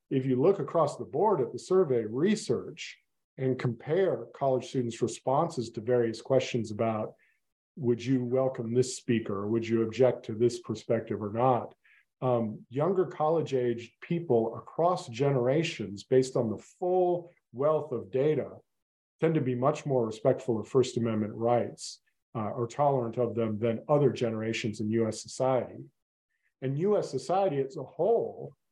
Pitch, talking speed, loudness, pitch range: 125 Hz, 155 wpm, -29 LUFS, 115-135 Hz